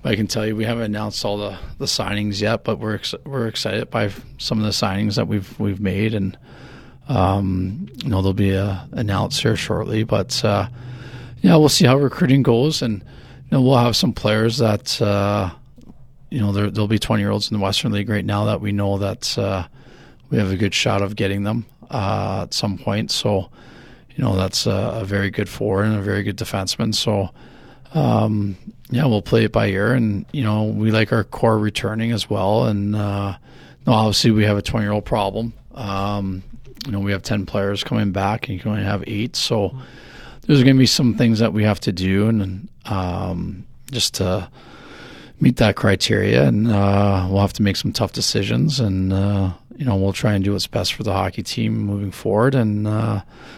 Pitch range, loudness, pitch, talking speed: 100-115 Hz, -20 LUFS, 105 Hz, 210 wpm